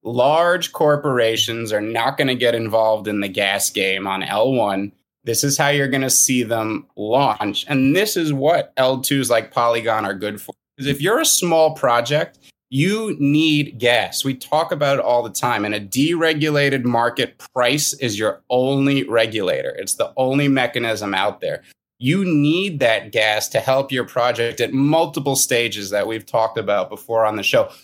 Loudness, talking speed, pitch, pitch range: -18 LUFS, 180 wpm, 130 Hz, 110-145 Hz